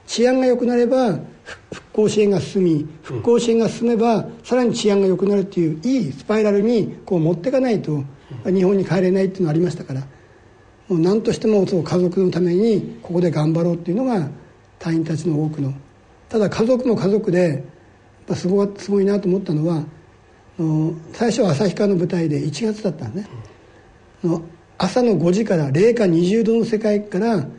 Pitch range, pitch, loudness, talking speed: 160-215 Hz, 185 Hz, -19 LUFS, 350 characters per minute